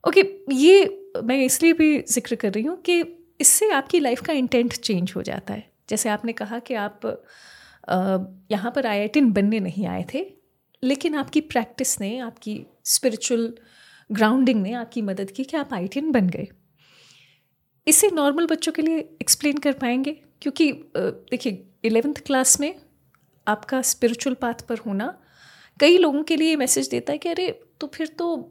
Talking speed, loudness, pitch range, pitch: 165 wpm, -21 LUFS, 230-315 Hz, 260 Hz